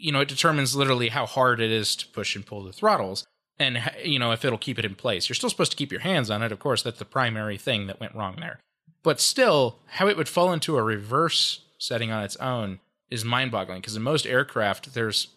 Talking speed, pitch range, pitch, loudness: 250 wpm, 110-145 Hz, 120 Hz, -25 LUFS